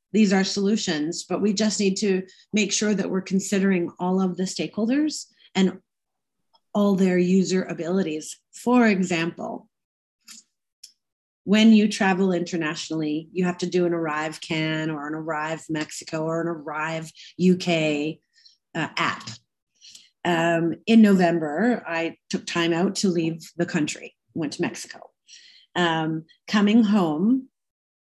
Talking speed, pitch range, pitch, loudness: 130 wpm, 165-205 Hz, 180 Hz, -23 LUFS